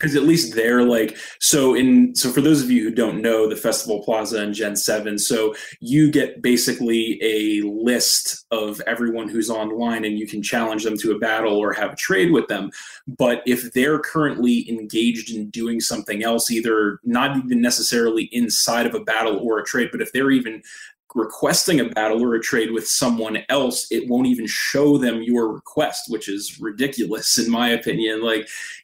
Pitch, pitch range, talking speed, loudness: 115 Hz, 110-125 Hz, 190 wpm, -20 LUFS